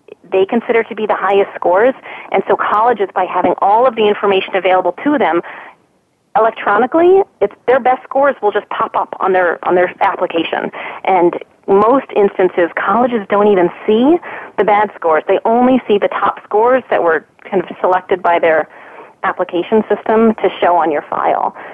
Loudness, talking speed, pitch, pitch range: -14 LUFS, 175 wpm, 205 Hz, 185-235 Hz